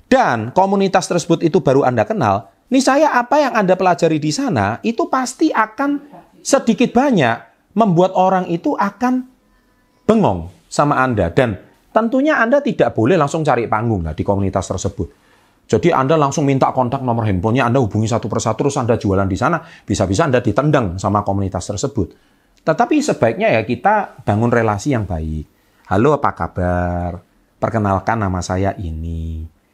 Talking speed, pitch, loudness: 155 wpm, 135 Hz, -17 LUFS